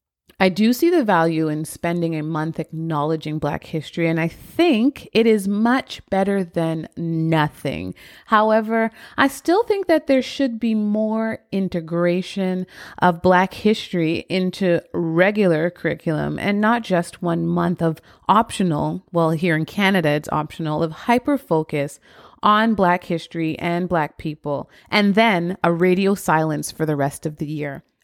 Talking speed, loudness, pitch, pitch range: 150 wpm, -20 LUFS, 175 Hz, 160-210 Hz